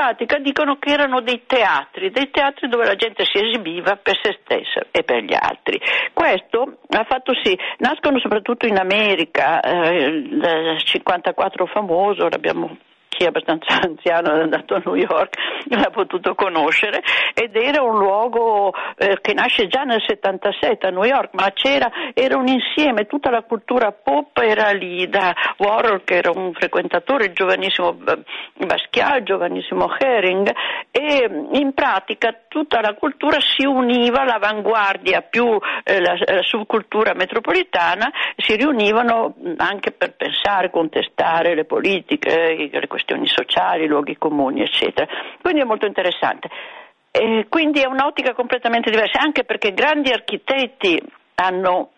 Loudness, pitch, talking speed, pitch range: -18 LUFS, 230 Hz, 140 wpm, 195-280 Hz